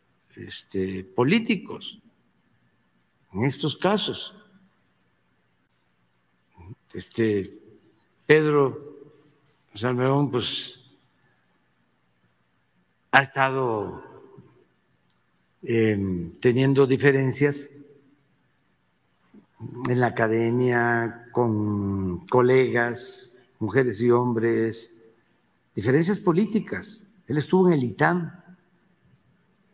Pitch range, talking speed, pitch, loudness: 105-150 Hz, 60 wpm, 125 Hz, -23 LUFS